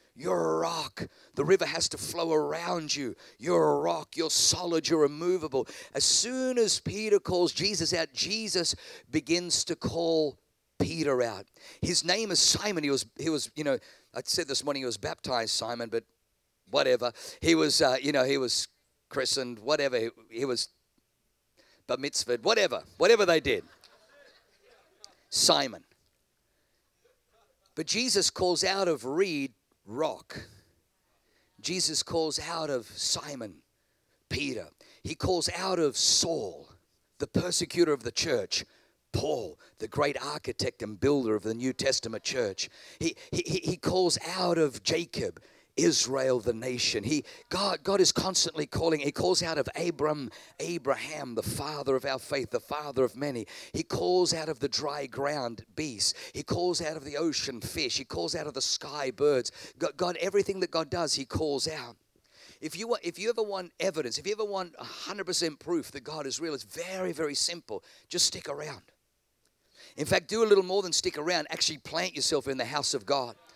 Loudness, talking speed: -29 LUFS, 170 wpm